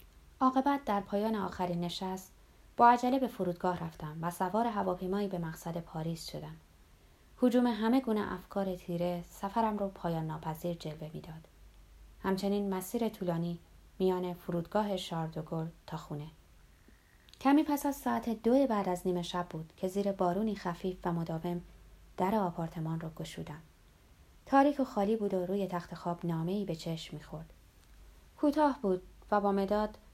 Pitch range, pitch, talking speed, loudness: 170-210 Hz, 185 Hz, 145 wpm, -33 LUFS